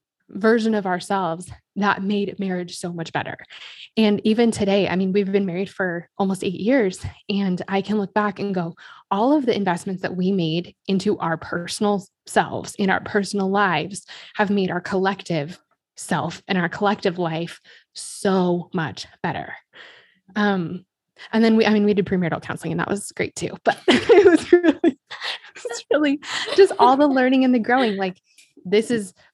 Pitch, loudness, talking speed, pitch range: 195 Hz, -21 LUFS, 180 wpm, 180-215 Hz